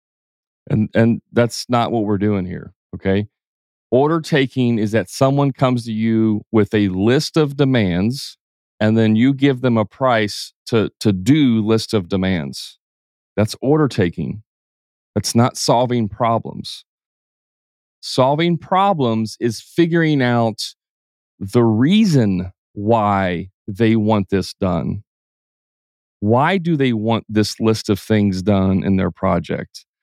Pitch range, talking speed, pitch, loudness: 100-125 Hz, 130 wpm, 110 Hz, -18 LUFS